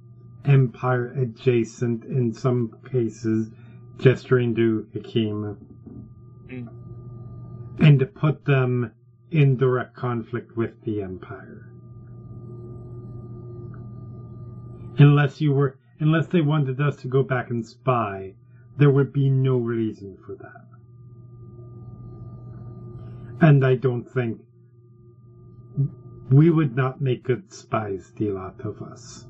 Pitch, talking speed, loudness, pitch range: 120 Hz, 105 wpm, -22 LUFS, 120-130 Hz